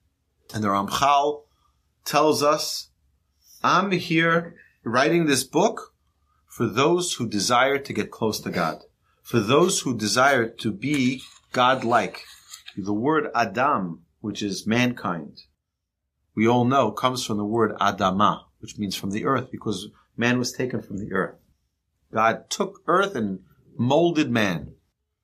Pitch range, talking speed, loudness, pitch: 95-140 Hz, 140 wpm, -23 LUFS, 110 Hz